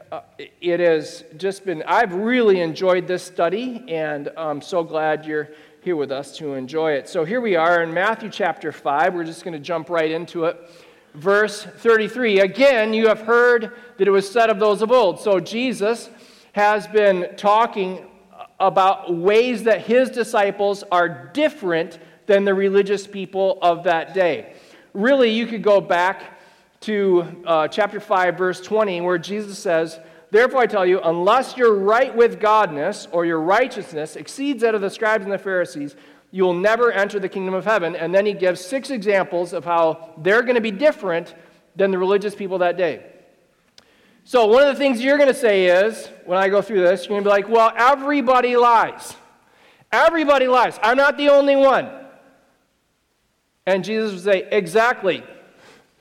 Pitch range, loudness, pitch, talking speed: 175-225 Hz, -19 LUFS, 195 Hz, 180 wpm